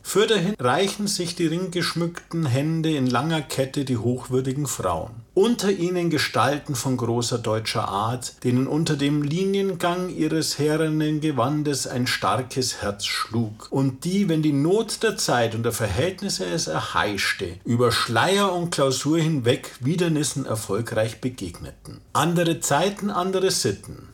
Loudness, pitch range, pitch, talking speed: -23 LUFS, 125-175 Hz, 145 Hz, 135 wpm